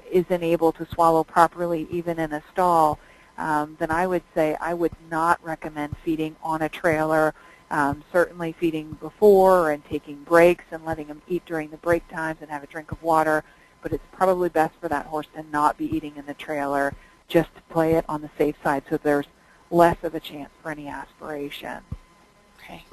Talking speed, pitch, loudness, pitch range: 195 wpm, 160 Hz, -23 LUFS, 150-170 Hz